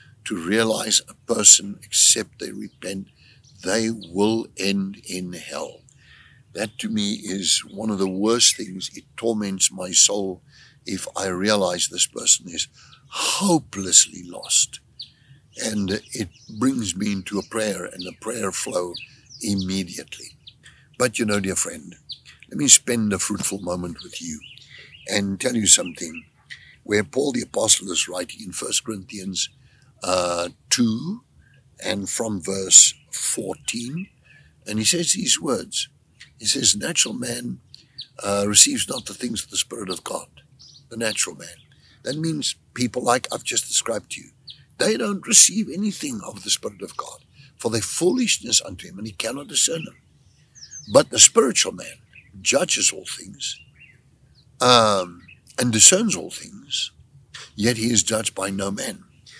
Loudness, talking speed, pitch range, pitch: -19 LUFS, 145 wpm, 95-125 Hz, 110 Hz